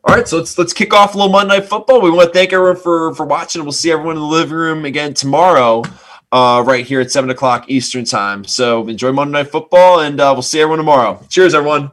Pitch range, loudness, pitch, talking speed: 130-175 Hz, -12 LUFS, 155 Hz, 250 wpm